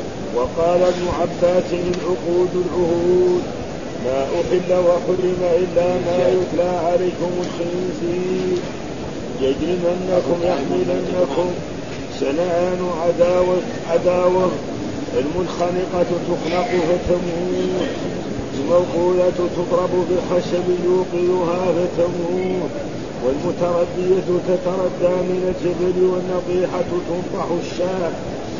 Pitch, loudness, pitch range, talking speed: 180 Hz, -20 LUFS, 175-180 Hz, 70 wpm